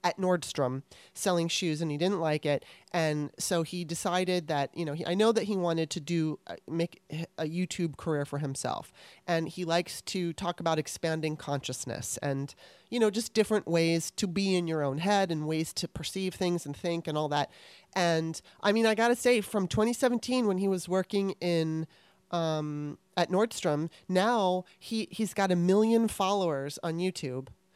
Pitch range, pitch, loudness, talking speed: 155-195 Hz, 170 Hz, -30 LUFS, 185 wpm